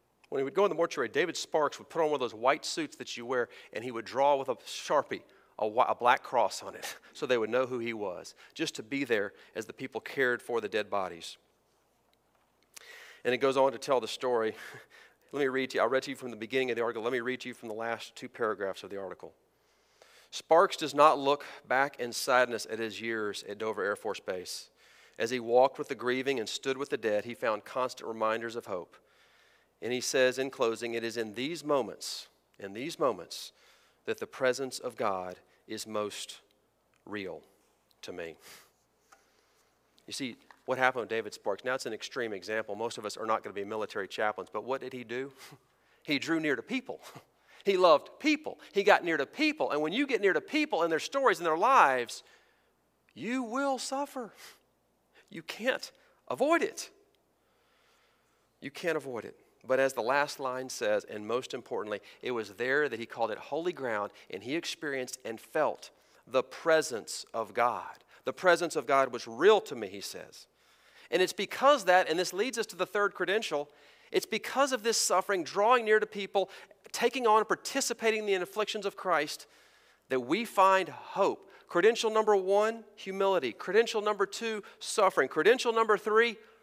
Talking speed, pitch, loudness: 200 wpm, 175 Hz, -31 LUFS